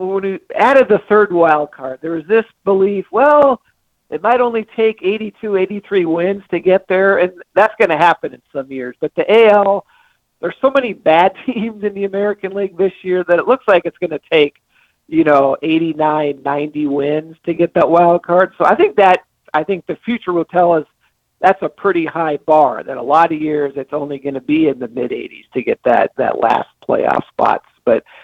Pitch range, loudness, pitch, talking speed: 155-205 Hz, -15 LUFS, 180 Hz, 215 wpm